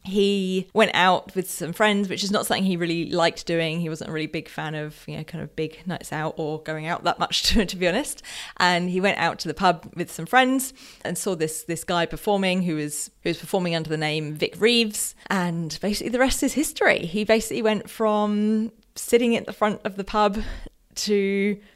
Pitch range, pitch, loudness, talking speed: 165-215 Hz, 185 Hz, -23 LUFS, 225 wpm